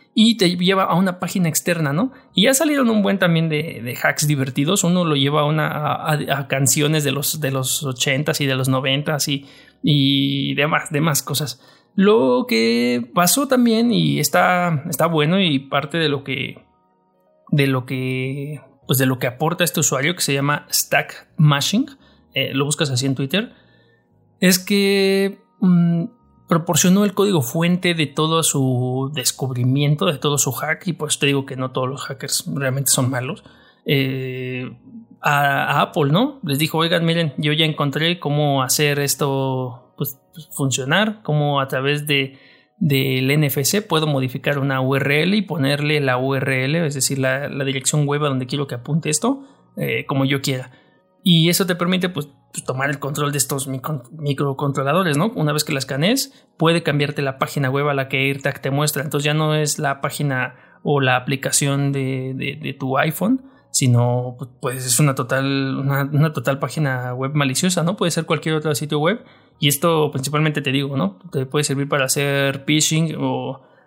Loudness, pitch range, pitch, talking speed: -19 LUFS, 135-165 Hz, 145 Hz, 180 wpm